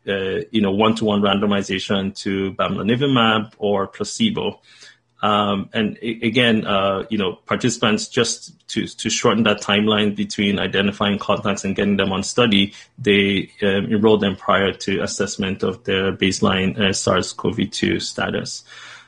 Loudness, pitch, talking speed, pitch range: -19 LUFS, 100 Hz, 135 wpm, 100-110 Hz